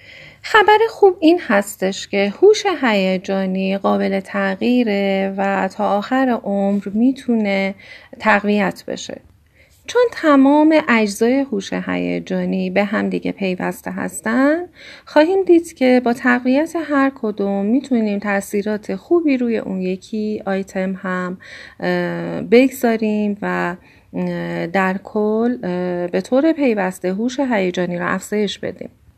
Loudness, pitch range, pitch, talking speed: -18 LUFS, 190-260 Hz, 205 Hz, 110 wpm